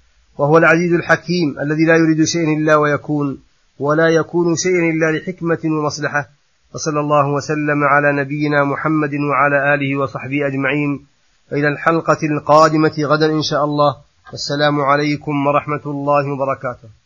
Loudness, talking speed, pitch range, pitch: -16 LUFS, 130 wpm, 145-155 Hz, 145 Hz